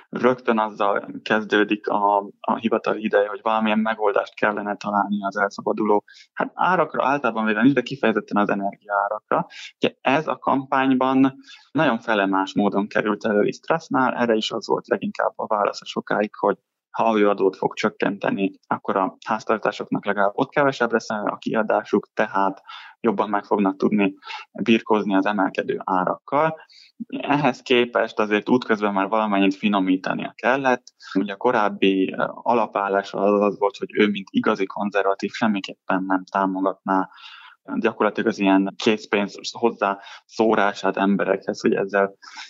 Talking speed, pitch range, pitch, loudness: 140 wpm, 100-115 Hz, 105 Hz, -22 LUFS